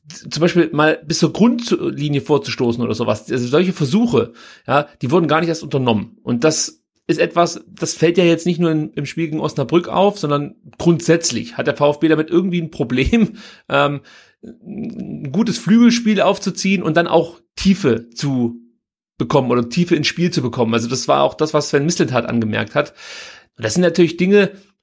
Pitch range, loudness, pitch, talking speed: 140-180 Hz, -17 LUFS, 160 Hz, 180 wpm